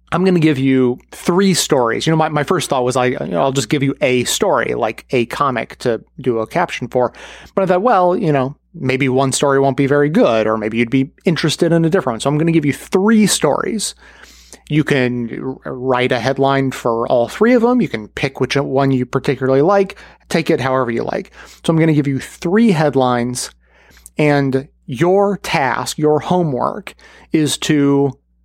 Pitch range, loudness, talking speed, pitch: 130-170 Hz, -16 LUFS, 210 wpm, 140 Hz